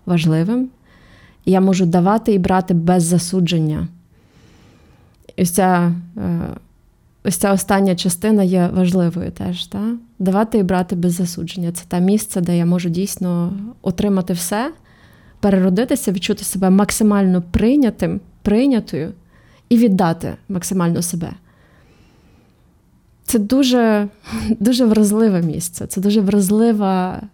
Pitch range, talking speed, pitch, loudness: 175-210 Hz, 110 wpm, 190 Hz, -17 LUFS